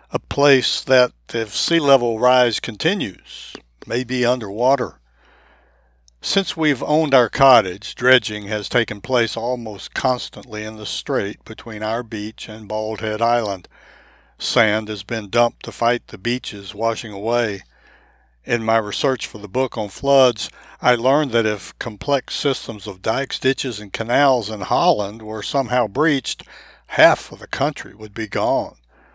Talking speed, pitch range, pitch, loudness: 150 wpm, 105-130 Hz, 115 Hz, -19 LUFS